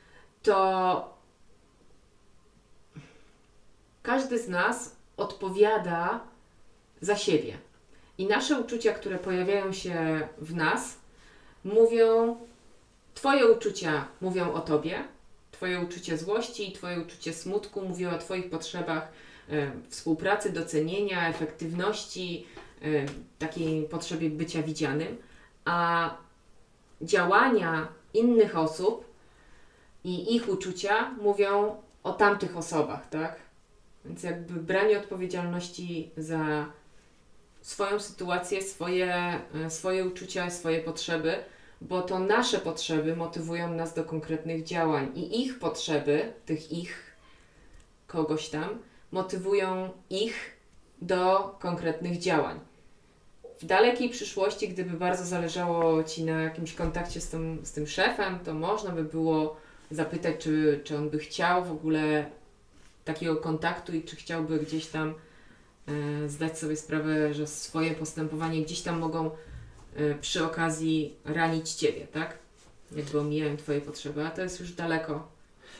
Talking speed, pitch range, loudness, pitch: 115 wpm, 155-190 Hz, -29 LUFS, 165 Hz